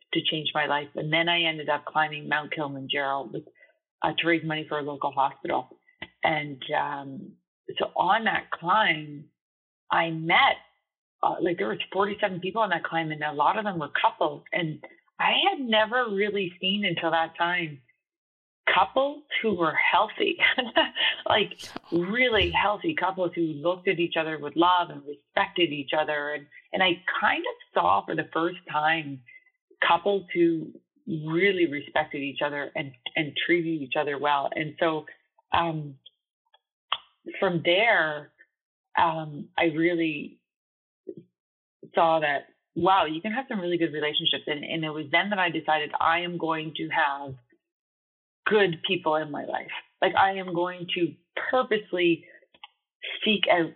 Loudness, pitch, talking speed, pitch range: -26 LUFS, 165 Hz, 155 wpm, 150-195 Hz